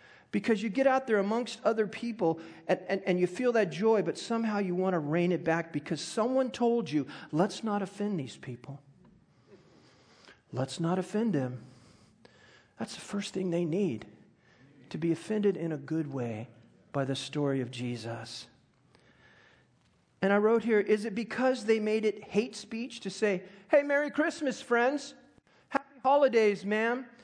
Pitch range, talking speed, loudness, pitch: 160-230 Hz, 165 wpm, -30 LUFS, 200 Hz